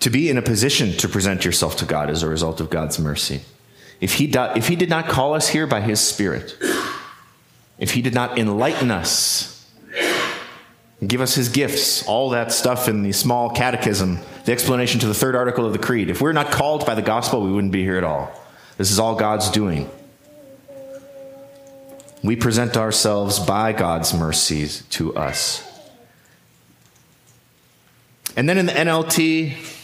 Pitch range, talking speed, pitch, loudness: 95-145 Hz, 175 wpm, 115 Hz, -19 LUFS